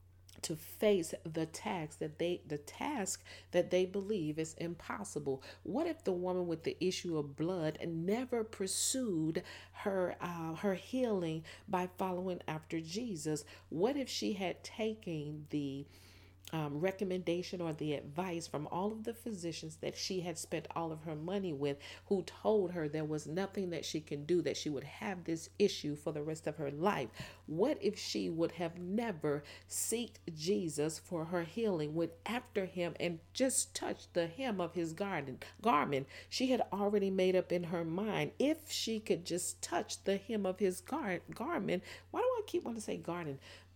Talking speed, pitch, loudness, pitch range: 175 wpm, 175 Hz, -38 LUFS, 155-200 Hz